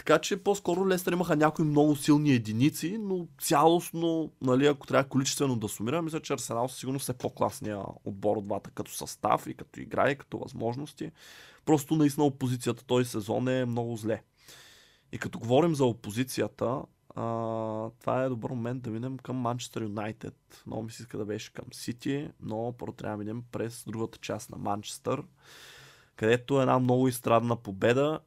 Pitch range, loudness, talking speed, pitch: 110-145 Hz, -30 LUFS, 175 wpm, 125 Hz